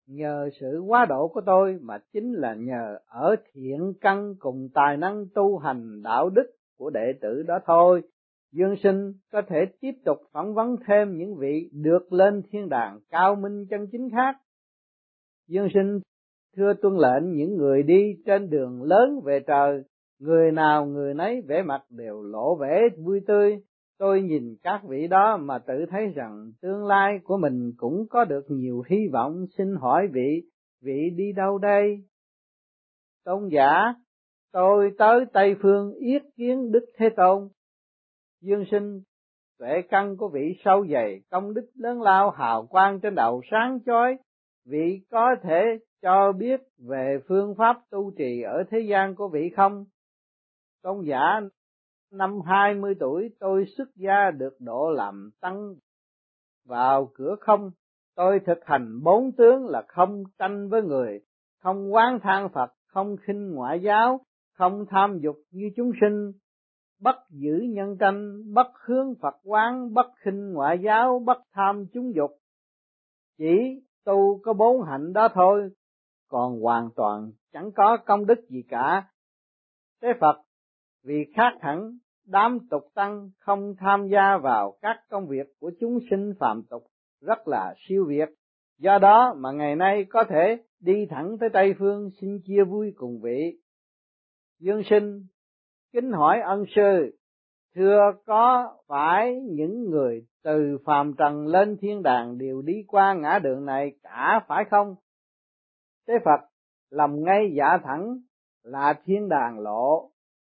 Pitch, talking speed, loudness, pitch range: 195 Hz, 155 wpm, -23 LUFS, 150-210 Hz